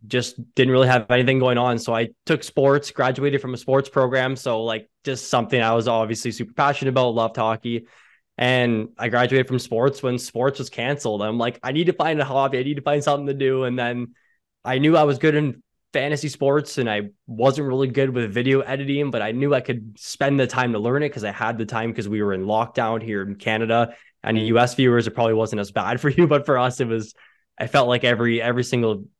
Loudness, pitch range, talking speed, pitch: -21 LUFS, 115-135 Hz, 240 wpm, 125 Hz